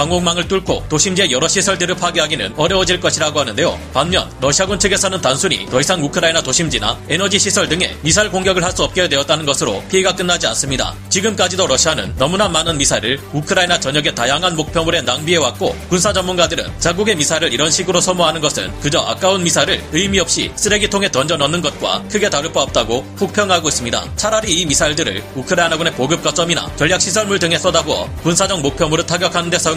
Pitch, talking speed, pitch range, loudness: 170 Hz, 480 characters per minute, 150-190 Hz, -15 LUFS